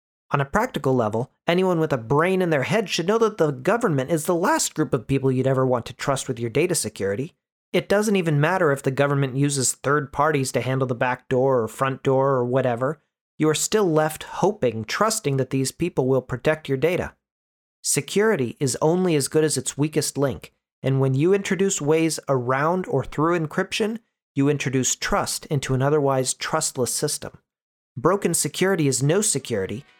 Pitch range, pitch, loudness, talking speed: 130-165 Hz, 145 Hz, -22 LUFS, 190 wpm